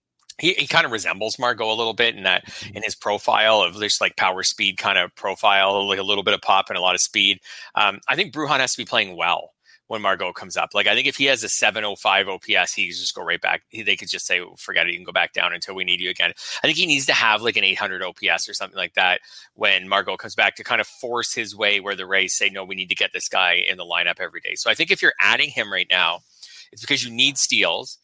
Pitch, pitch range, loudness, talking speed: 100 Hz, 95-120 Hz, -20 LUFS, 280 wpm